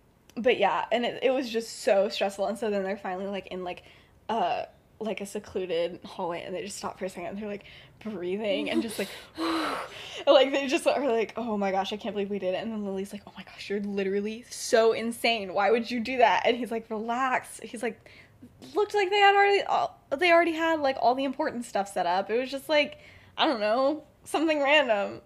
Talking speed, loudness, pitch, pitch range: 235 wpm, -27 LUFS, 225 Hz, 200-280 Hz